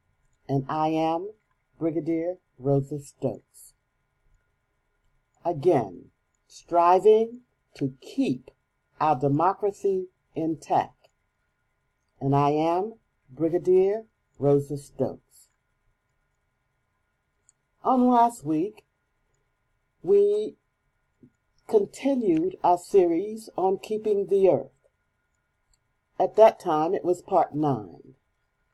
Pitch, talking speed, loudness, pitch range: 165 Hz, 75 wpm, -25 LUFS, 140-215 Hz